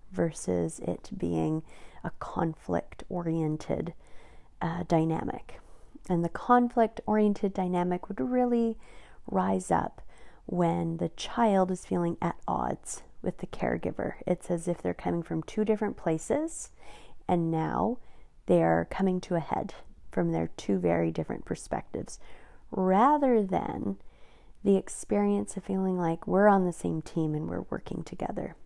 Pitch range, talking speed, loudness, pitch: 155-205 Hz, 135 wpm, -30 LUFS, 175 Hz